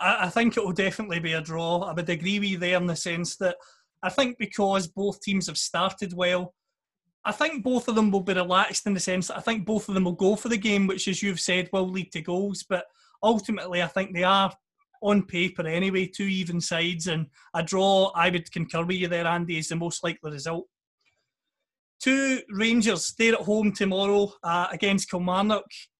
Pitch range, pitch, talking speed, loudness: 175-205 Hz, 190 Hz, 210 wpm, -26 LUFS